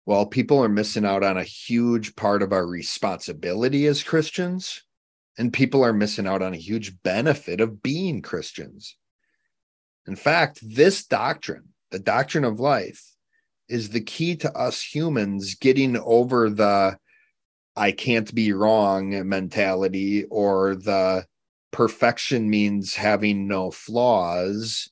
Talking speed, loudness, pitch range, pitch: 130 wpm, -22 LUFS, 95-125 Hz, 105 Hz